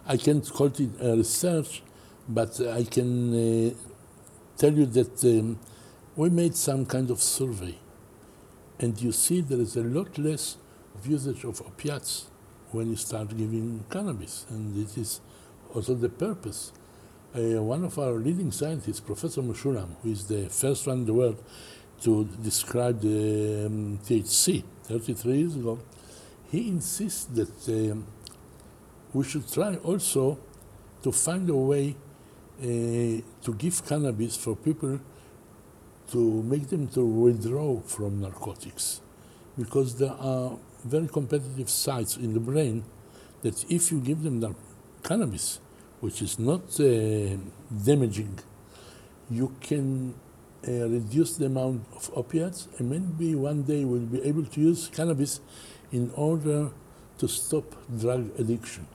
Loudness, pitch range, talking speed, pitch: -28 LUFS, 110-140 Hz, 135 wpm, 120 Hz